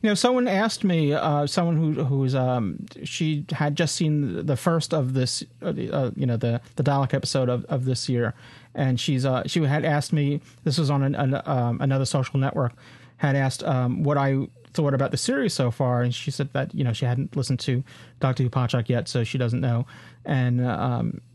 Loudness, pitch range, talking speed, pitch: -24 LUFS, 125-150 Hz, 210 wpm, 135 Hz